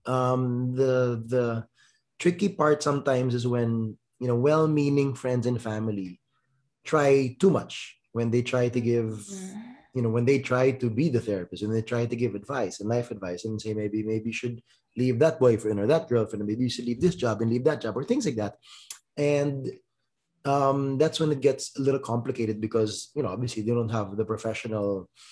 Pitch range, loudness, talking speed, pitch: 110-140 Hz, -27 LUFS, 200 wpm, 125 Hz